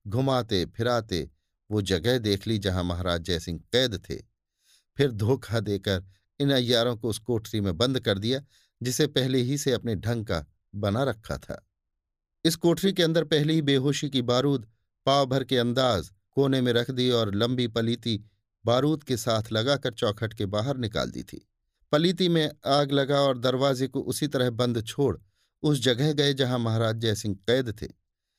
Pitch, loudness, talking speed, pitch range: 120 Hz, -26 LUFS, 175 wpm, 105-135 Hz